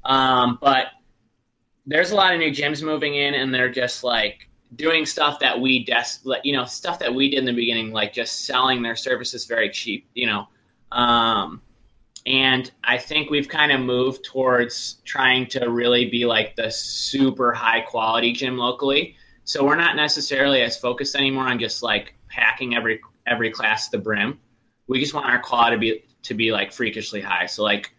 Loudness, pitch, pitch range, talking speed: -20 LUFS, 125 Hz, 115-135 Hz, 190 wpm